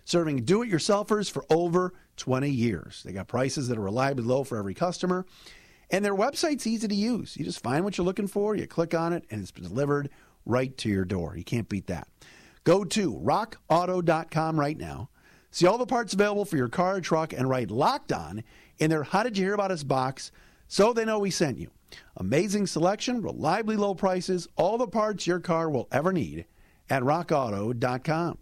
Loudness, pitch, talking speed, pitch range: -27 LUFS, 165 Hz, 200 wpm, 125-190 Hz